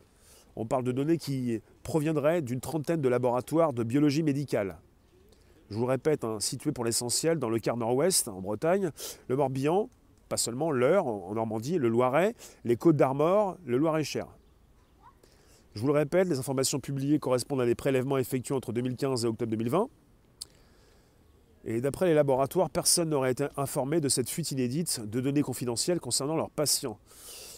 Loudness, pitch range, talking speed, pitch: -28 LUFS, 115-150 Hz, 170 wpm, 130 Hz